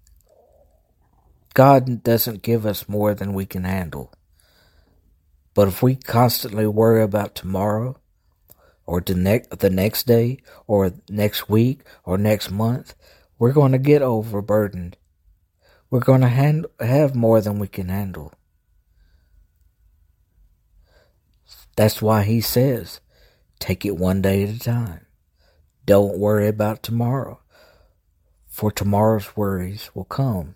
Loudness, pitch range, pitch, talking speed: -20 LUFS, 90-115 Hz, 100 Hz, 125 wpm